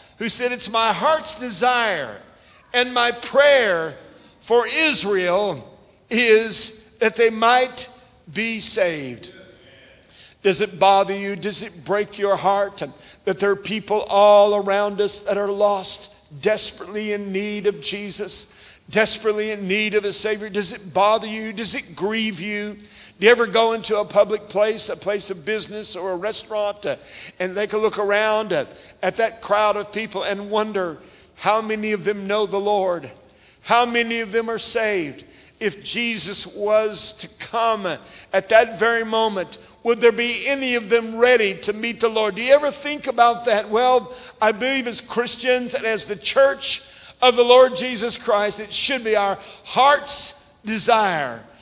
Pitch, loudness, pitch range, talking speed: 215 Hz, -19 LUFS, 205-235 Hz, 165 wpm